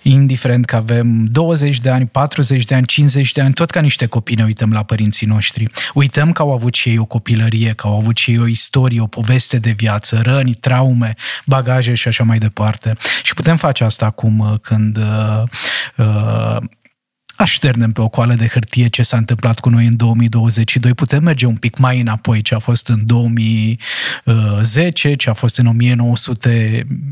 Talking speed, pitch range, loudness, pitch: 185 wpm, 115-130 Hz, -14 LUFS, 120 Hz